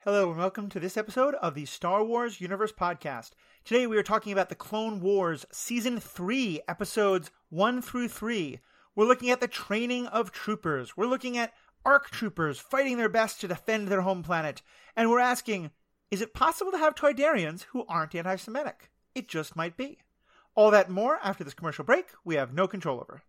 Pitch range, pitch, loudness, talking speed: 180-245 Hz, 210 Hz, -28 LUFS, 195 wpm